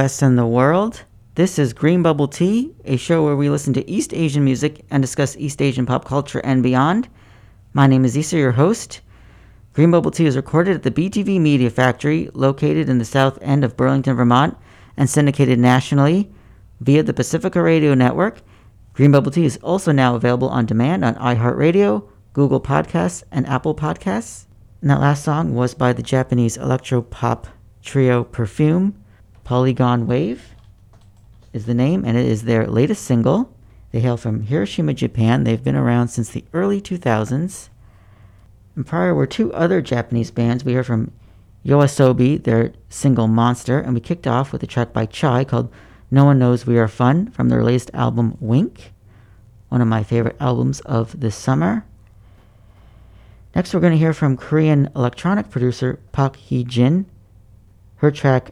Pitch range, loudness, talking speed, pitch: 110-145 Hz, -18 LUFS, 170 wpm, 125 Hz